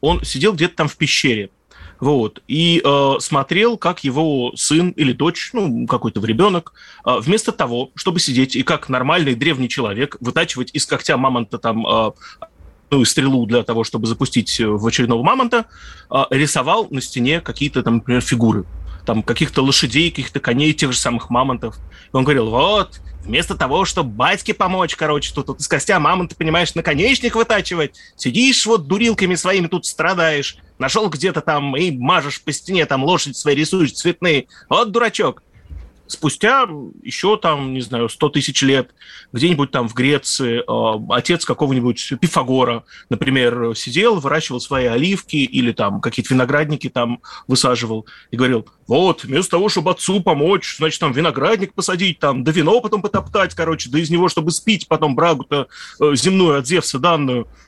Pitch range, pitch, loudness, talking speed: 125-175 Hz, 145 Hz, -17 LUFS, 165 wpm